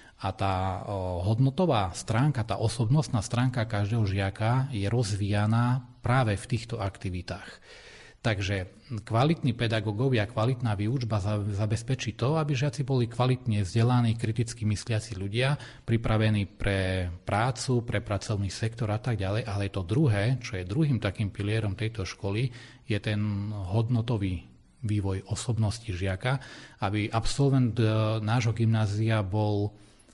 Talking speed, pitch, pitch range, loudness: 120 wpm, 110 Hz, 100-120 Hz, -28 LUFS